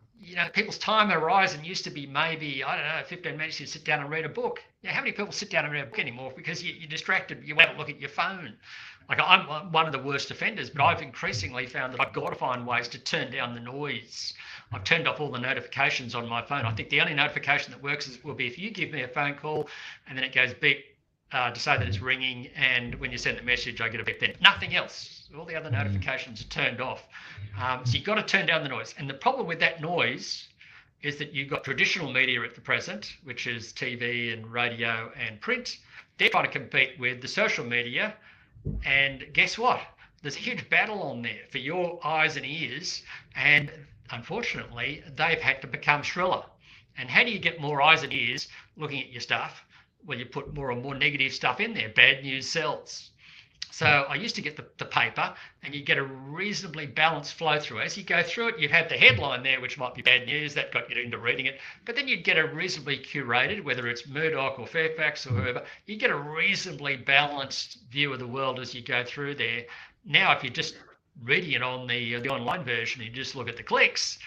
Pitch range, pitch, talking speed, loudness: 125-160 Hz, 140 Hz, 235 wpm, -26 LUFS